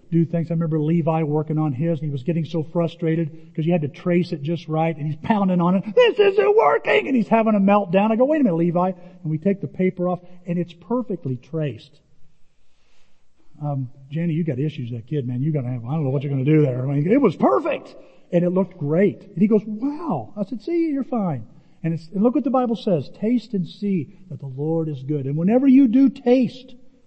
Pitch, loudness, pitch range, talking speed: 170 Hz, -21 LUFS, 155-210 Hz, 240 wpm